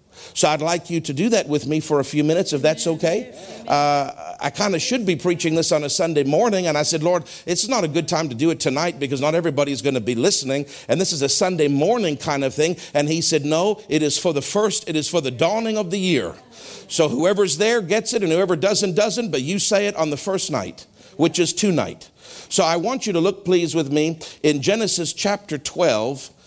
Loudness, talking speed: -20 LUFS, 245 wpm